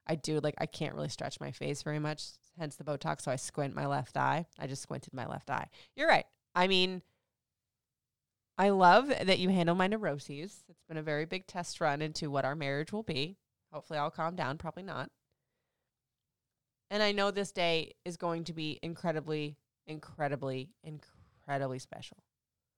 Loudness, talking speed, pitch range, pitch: -33 LUFS, 180 wpm, 145-175 Hz, 155 Hz